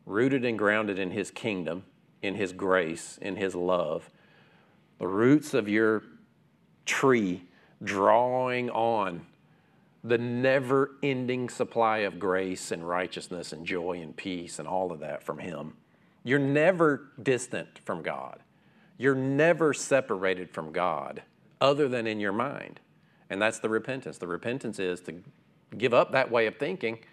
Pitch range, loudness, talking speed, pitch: 95-130 Hz, -28 LUFS, 145 wpm, 115 Hz